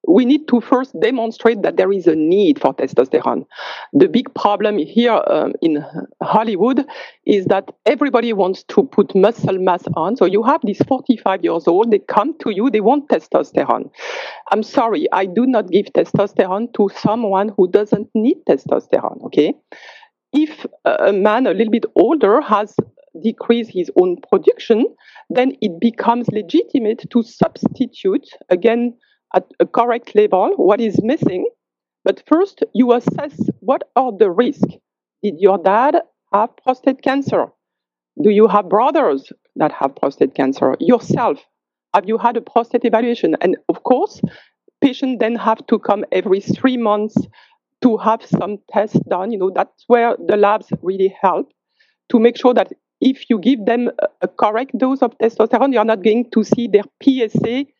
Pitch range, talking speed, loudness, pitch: 210-265 Hz, 160 wpm, -16 LUFS, 235 Hz